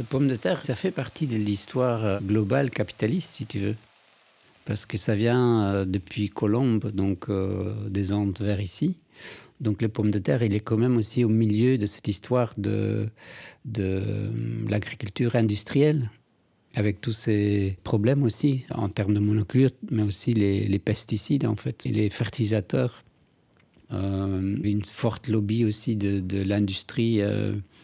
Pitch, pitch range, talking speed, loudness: 110 Hz, 100-120 Hz, 155 wpm, -26 LUFS